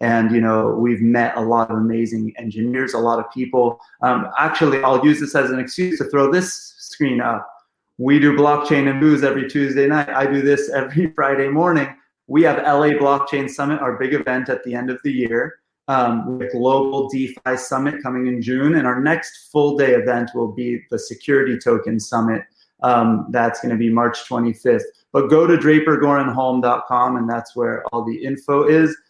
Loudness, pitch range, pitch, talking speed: -18 LUFS, 120-145 Hz, 130 Hz, 190 wpm